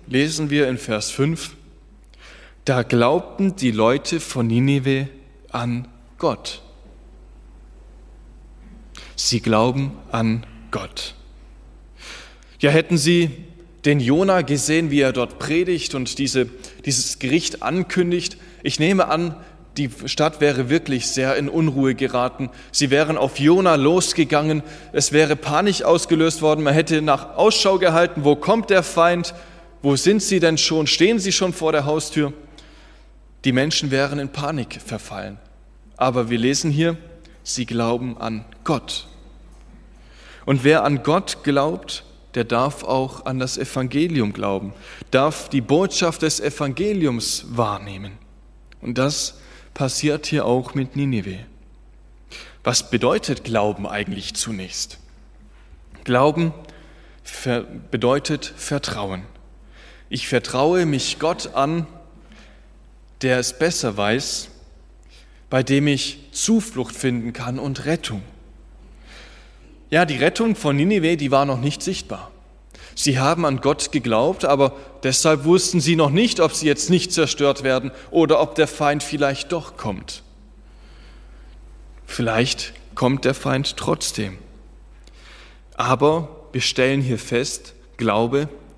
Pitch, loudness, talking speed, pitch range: 140 Hz, -20 LUFS, 125 wpm, 120-160 Hz